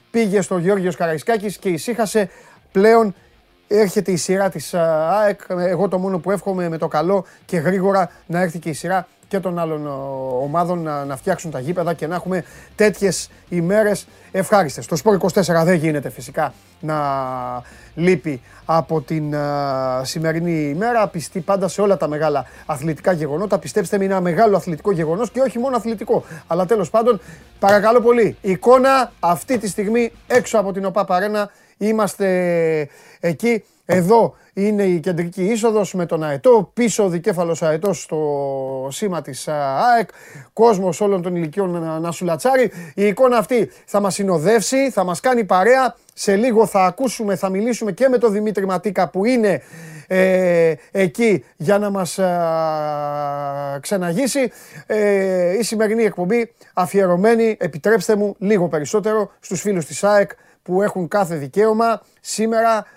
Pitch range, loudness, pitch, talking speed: 165-210 Hz, -18 LUFS, 190 Hz, 150 wpm